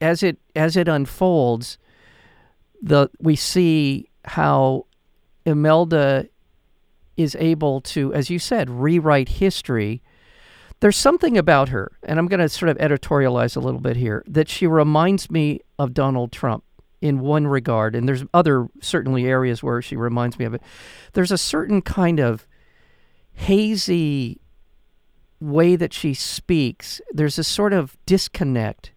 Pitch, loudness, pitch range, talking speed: 145 Hz, -20 LUFS, 125-165 Hz, 145 wpm